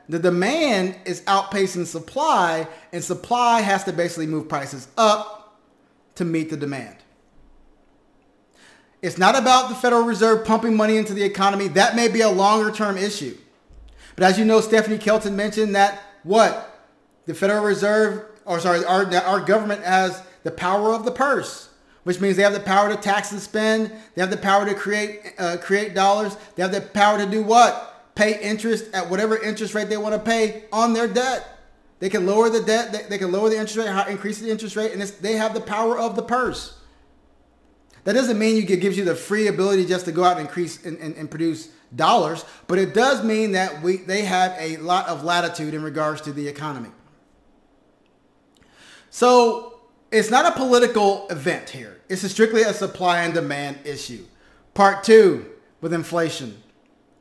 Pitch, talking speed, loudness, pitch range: 200 Hz, 185 wpm, -20 LUFS, 180-220 Hz